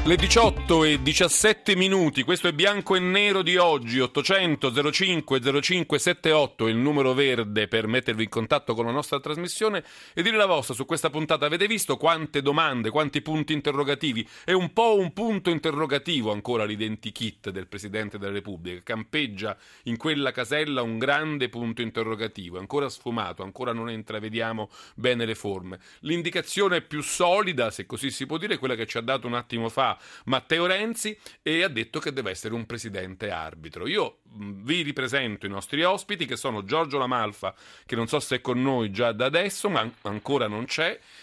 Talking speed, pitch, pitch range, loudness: 175 wpm, 135 Hz, 115-165 Hz, -25 LUFS